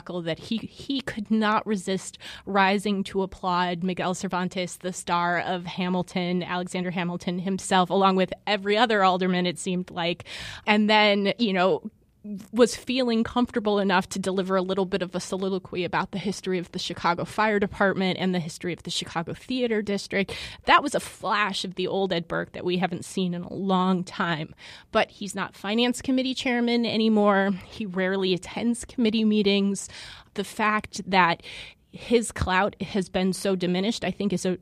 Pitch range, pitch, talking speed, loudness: 180-210 Hz, 190 Hz, 175 wpm, -25 LUFS